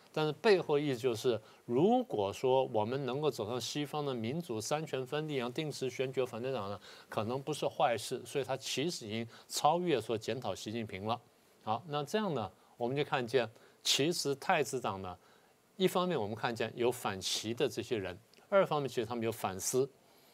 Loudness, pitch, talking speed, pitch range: -35 LUFS, 130 Hz, 290 characters per minute, 115-150 Hz